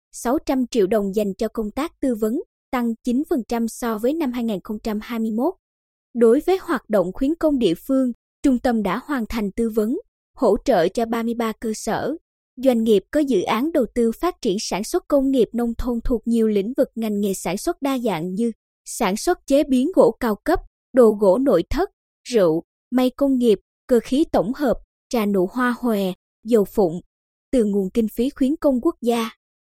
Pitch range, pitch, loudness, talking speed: 220-275 Hz, 240 Hz, -21 LUFS, 190 wpm